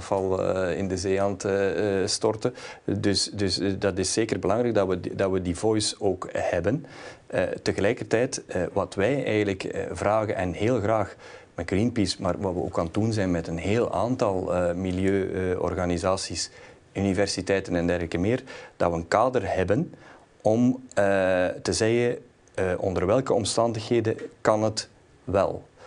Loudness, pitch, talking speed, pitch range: -26 LUFS, 100 Hz, 155 wpm, 90-110 Hz